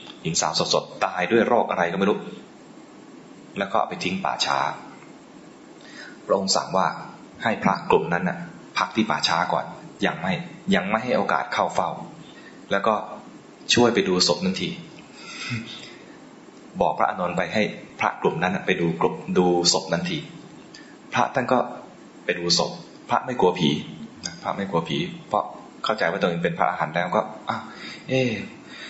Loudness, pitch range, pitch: -23 LUFS, 85-115 Hz, 95 Hz